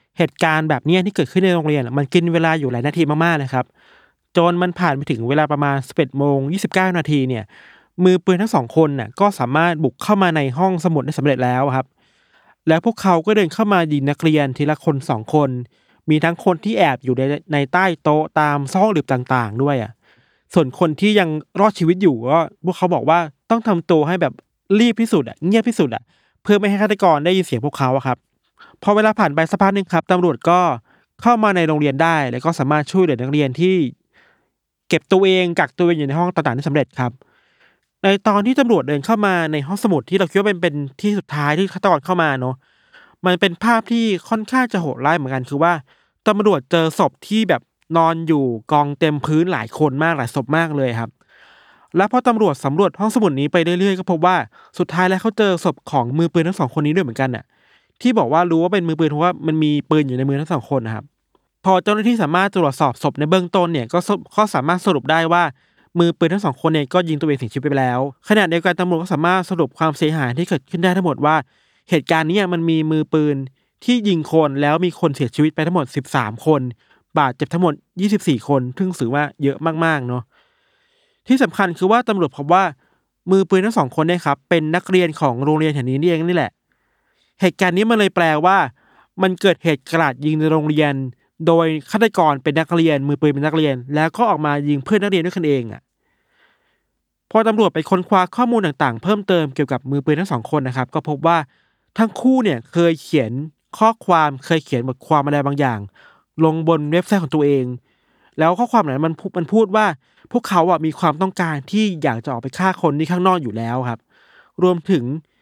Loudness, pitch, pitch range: -17 LUFS, 165 Hz, 145-185 Hz